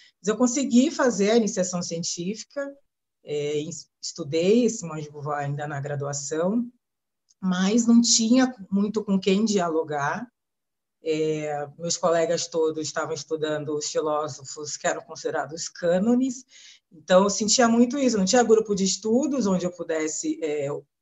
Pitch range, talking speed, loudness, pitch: 155-230 Hz, 135 wpm, -24 LUFS, 175 Hz